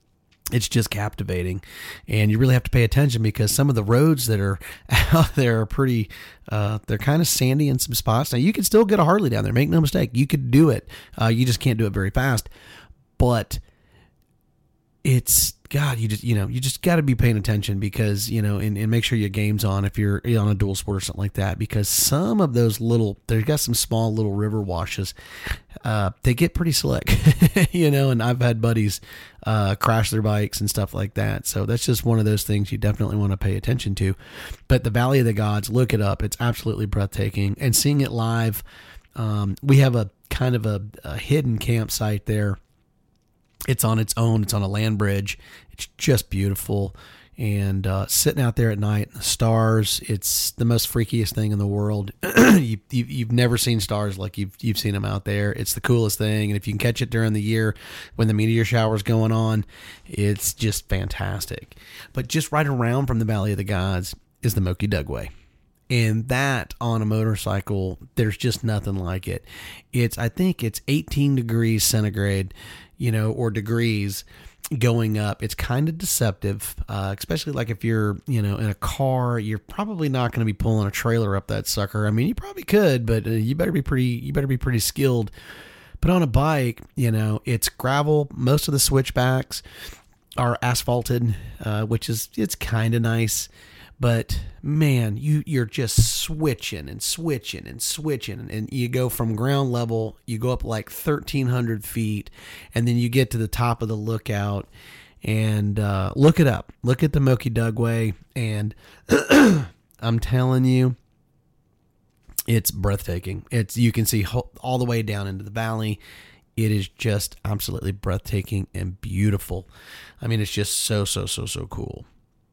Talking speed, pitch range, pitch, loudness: 195 wpm, 105-125 Hz, 110 Hz, -22 LUFS